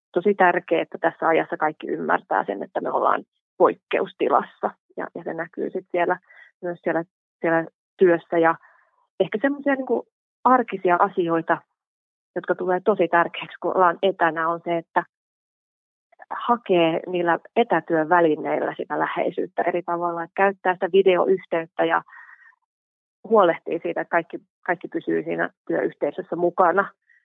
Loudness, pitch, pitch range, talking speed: -23 LUFS, 175 Hz, 165-190 Hz, 130 wpm